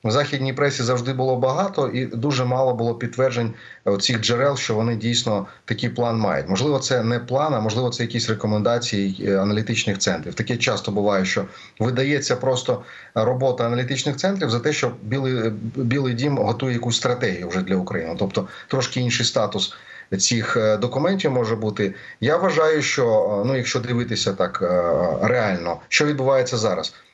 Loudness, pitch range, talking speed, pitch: -21 LUFS, 110-130 Hz, 155 wpm, 120 Hz